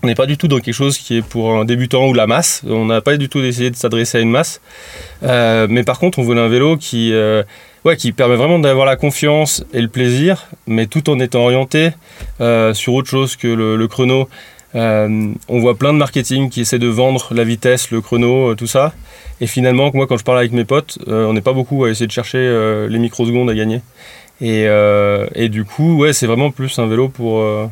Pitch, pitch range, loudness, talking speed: 125 Hz, 115-135 Hz, -14 LUFS, 240 wpm